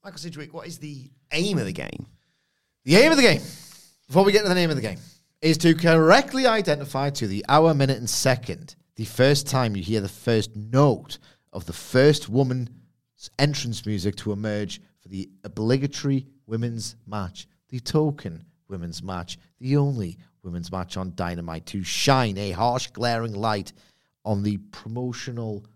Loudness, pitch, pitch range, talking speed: -23 LUFS, 120 Hz, 105-145 Hz, 170 wpm